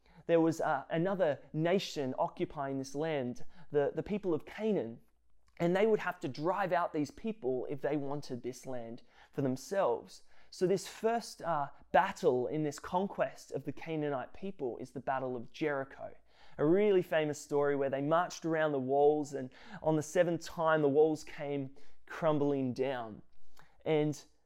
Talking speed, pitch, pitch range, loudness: 165 wpm, 150 Hz, 140-170 Hz, -34 LUFS